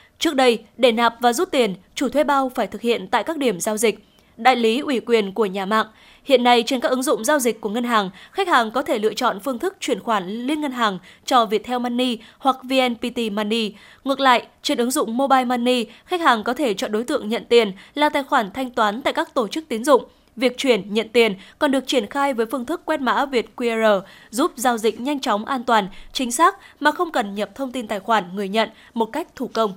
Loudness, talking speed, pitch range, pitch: -20 LUFS, 240 wpm, 220-275 Hz, 245 Hz